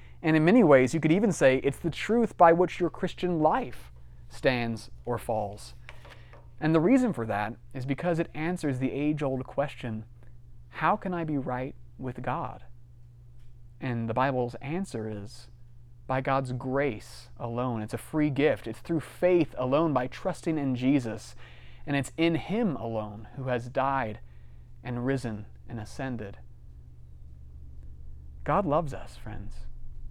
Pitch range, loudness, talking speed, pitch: 110-145 Hz, -28 LUFS, 150 wpm, 125 Hz